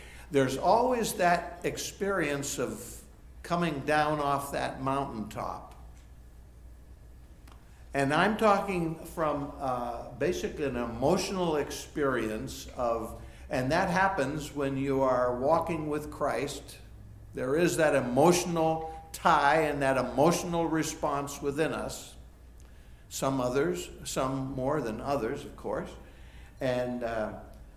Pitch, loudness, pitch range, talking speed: 135 Hz, -30 LUFS, 110-160 Hz, 110 wpm